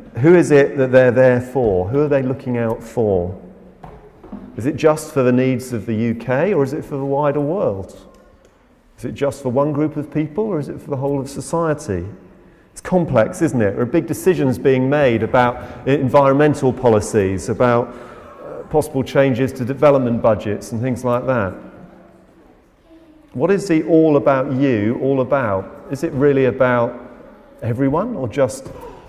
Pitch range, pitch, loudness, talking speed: 120-145 Hz, 130 Hz, -17 LUFS, 170 wpm